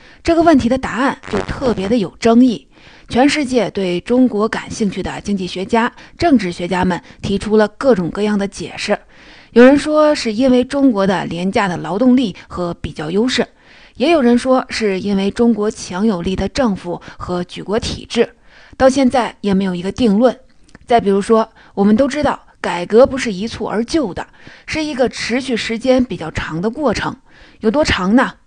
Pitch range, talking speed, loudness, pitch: 195-255 Hz, 270 characters per minute, -16 LUFS, 225 Hz